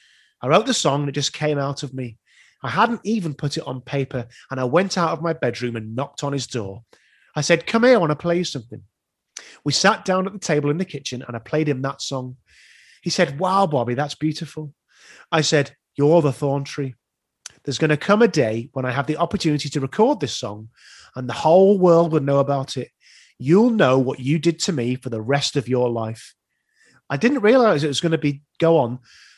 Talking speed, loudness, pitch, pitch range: 230 wpm, -20 LUFS, 145 Hz, 130-170 Hz